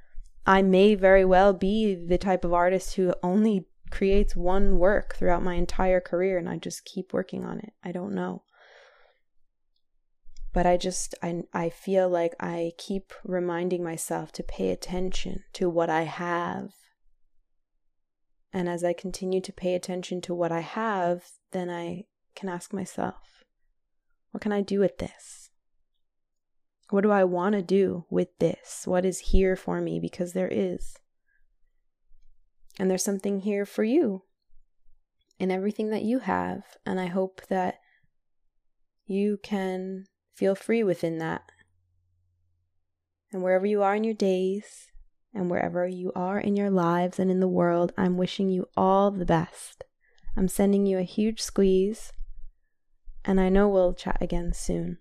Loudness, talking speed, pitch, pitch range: -27 LUFS, 155 wpm, 185 Hz, 175-195 Hz